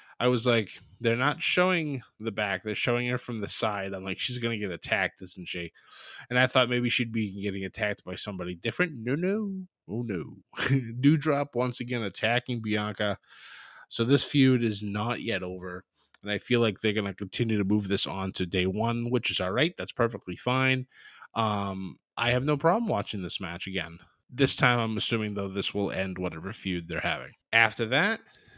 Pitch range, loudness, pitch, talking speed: 95-125 Hz, -28 LUFS, 110 Hz, 200 wpm